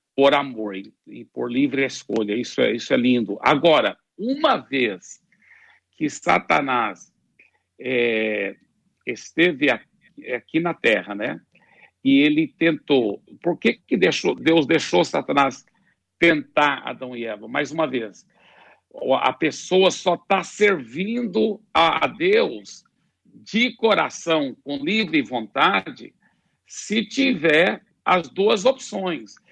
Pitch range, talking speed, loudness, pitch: 140-220 Hz, 115 wpm, -21 LUFS, 170 Hz